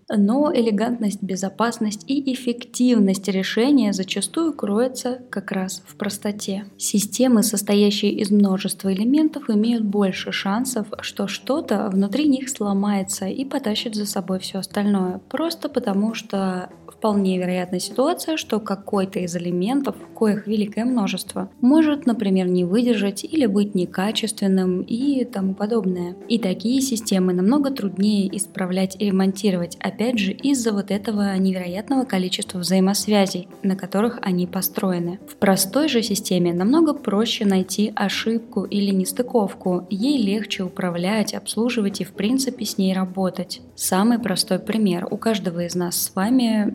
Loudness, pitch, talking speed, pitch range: -21 LUFS, 205 Hz, 135 wpm, 190-235 Hz